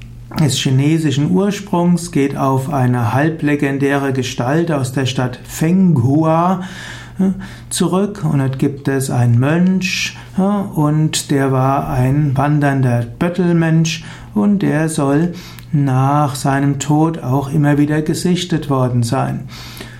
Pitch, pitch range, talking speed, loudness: 145 Hz, 135-165 Hz, 110 wpm, -15 LUFS